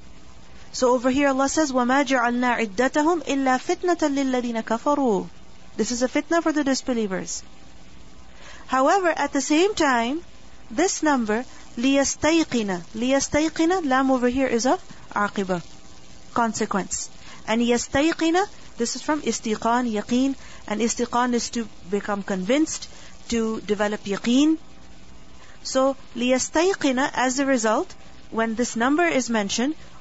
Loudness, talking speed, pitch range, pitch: -23 LUFS, 105 wpm, 220-280 Hz, 250 Hz